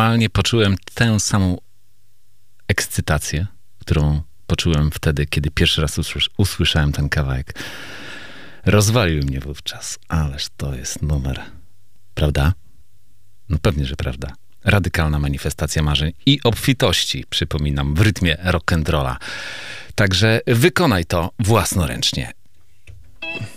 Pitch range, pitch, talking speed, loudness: 75-105 Hz, 90 Hz, 95 wpm, -19 LUFS